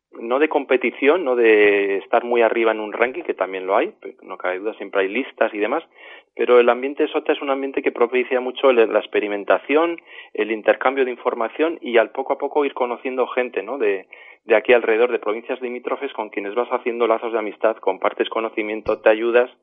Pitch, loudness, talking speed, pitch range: 125 Hz, -20 LUFS, 205 wpm, 115-145 Hz